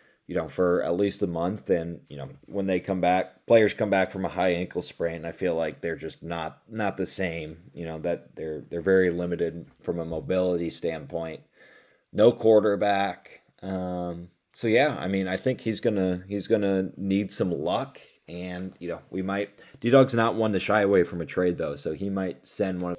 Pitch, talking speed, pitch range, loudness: 95 Hz, 205 wpm, 85-100 Hz, -26 LUFS